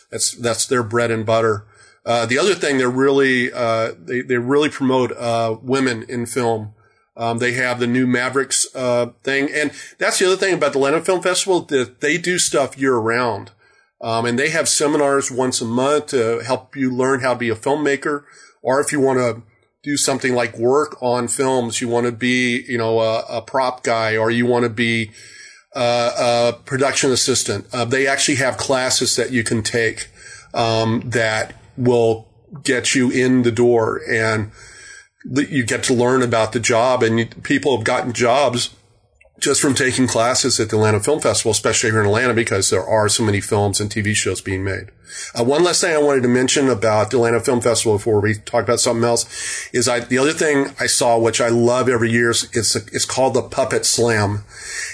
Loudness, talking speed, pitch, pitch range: -17 LUFS, 200 wpm, 120 Hz, 115-130 Hz